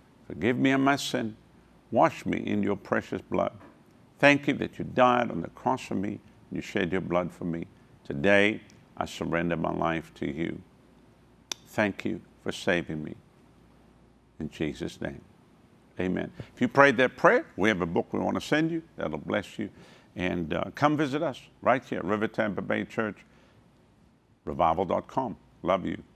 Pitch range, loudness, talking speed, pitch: 90-135 Hz, -28 LUFS, 175 wpm, 110 Hz